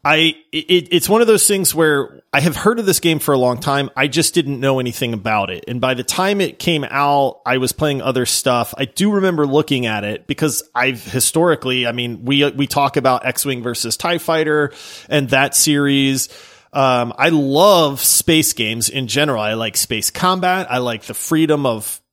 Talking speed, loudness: 205 wpm, -16 LUFS